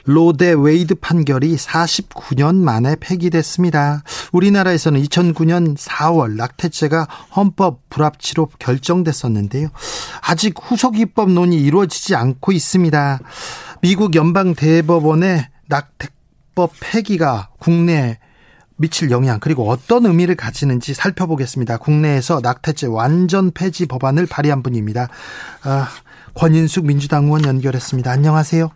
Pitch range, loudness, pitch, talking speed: 135-175 Hz, -16 LUFS, 155 Hz, 300 characters per minute